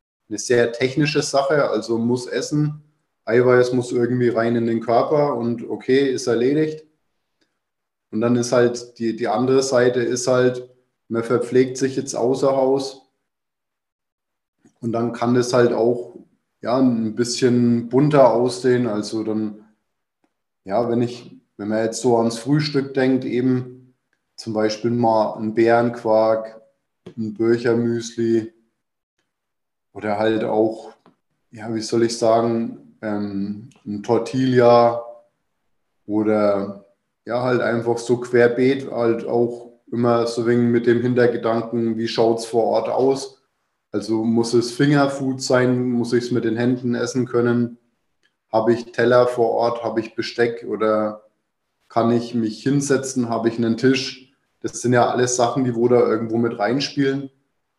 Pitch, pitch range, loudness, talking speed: 120 Hz, 115-125 Hz, -20 LUFS, 145 wpm